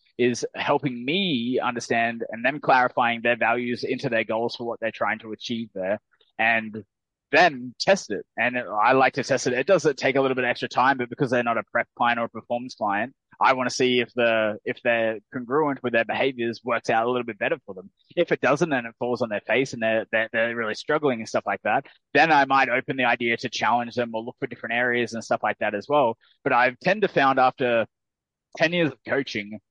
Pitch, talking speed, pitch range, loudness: 120 Hz, 240 wpm, 115-135 Hz, -23 LUFS